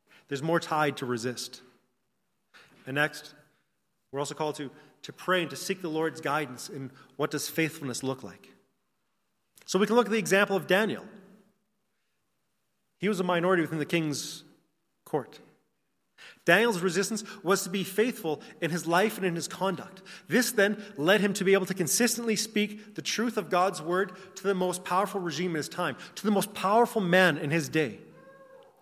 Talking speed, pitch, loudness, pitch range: 180 wpm, 185 Hz, -28 LUFS, 150-205 Hz